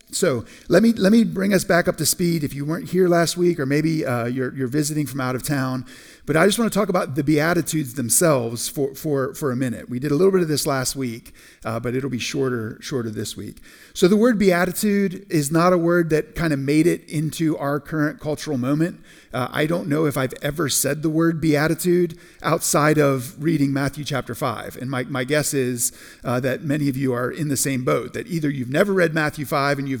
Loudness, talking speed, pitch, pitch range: -21 LUFS, 235 wpm, 150 Hz, 130-170 Hz